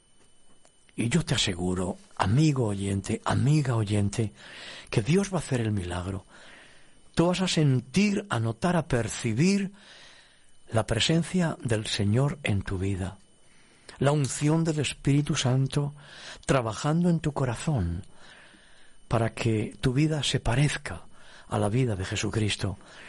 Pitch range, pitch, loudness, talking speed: 105-155 Hz, 125 Hz, -27 LUFS, 130 wpm